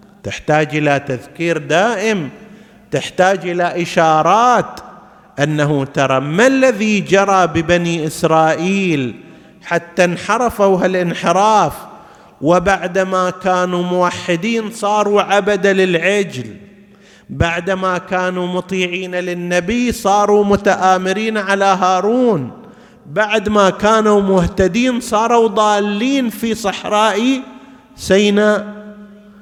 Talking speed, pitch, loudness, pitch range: 80 wpm, 195 Hz, -15 LUFS, 175-210 Hz